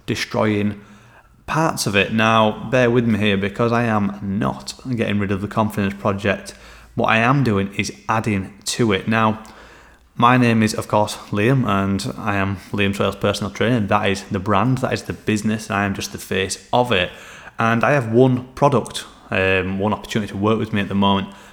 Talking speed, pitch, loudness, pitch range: 200 wpm, 105 Hz, -19 LUFS, 100-115 Hz